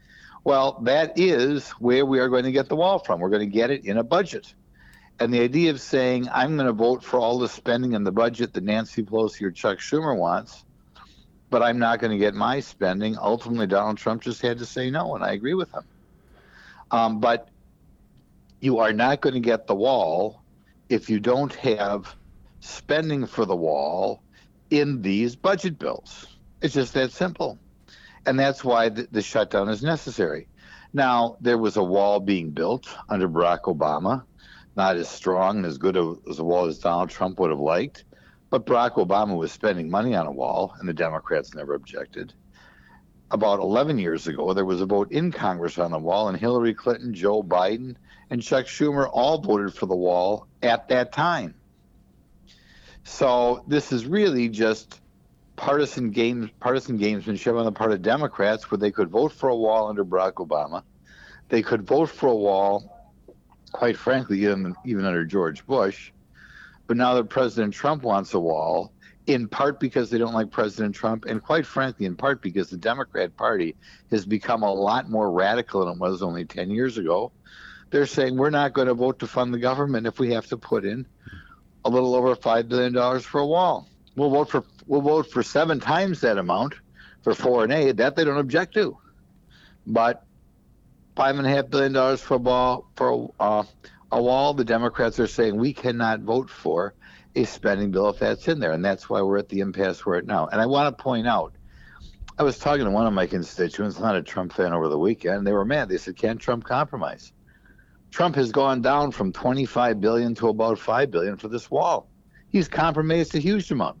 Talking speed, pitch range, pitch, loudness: 195 wpm, 105-135 Hz, 120 Hz, -23 LUFS